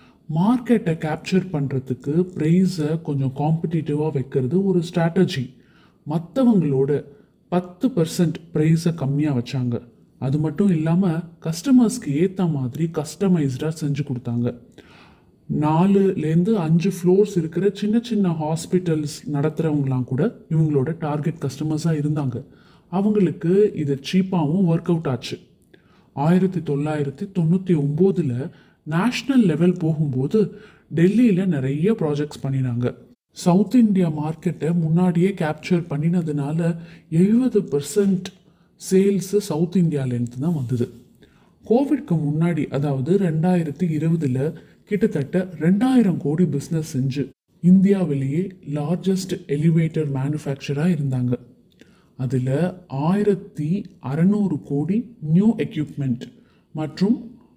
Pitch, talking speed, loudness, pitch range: 165 Hz, 80 wpm, -21 LUFS, 145-185 Hz